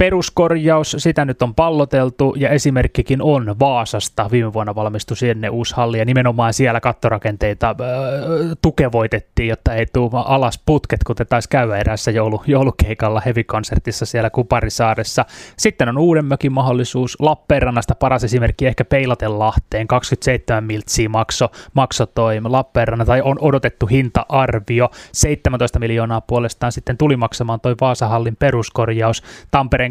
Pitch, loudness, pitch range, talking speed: 120 Hz, -17 LUFS, 115-135 Hz, 130 wpm